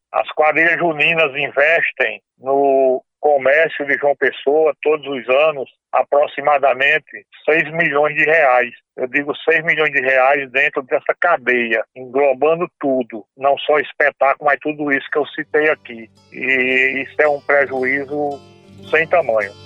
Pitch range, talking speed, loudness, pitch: 130-150 Hz, 135 wpm, -16 LUFS, 140 Hz